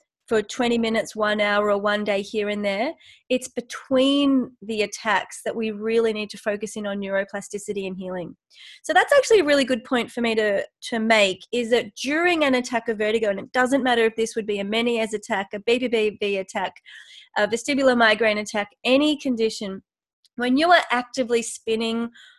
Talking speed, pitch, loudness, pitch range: 190 wpm, 225 Hz, -22 LUFS, 210-255 Hz